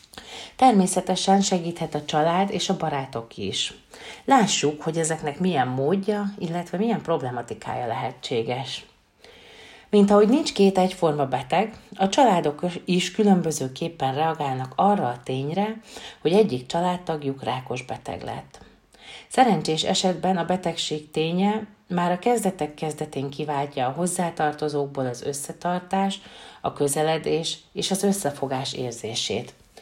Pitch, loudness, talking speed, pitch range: 170 Hz, -24 LUFS, 115 wpm, 145-195 Hz